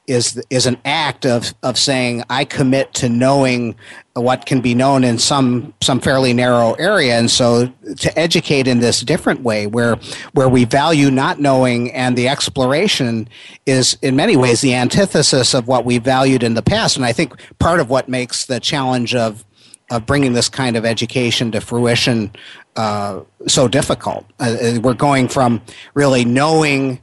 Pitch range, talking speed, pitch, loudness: 120-135 Hz, 175 wpm, 125 Hz, -15 LUFS